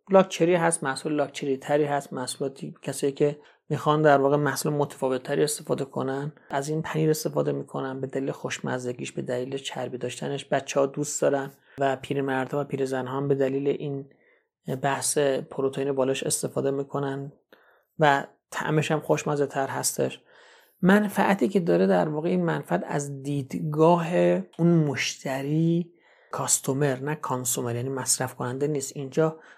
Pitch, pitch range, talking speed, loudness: 140 Hz, 135-155 Hz, 145 wpm, -26 LUFS